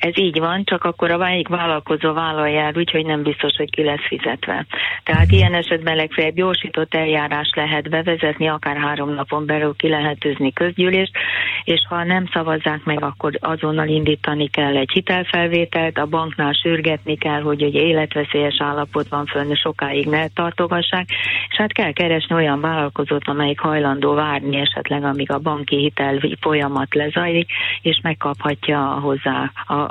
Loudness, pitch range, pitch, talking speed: -18 LUFS, 145-165 Hz, 155 Hz, 150 wpm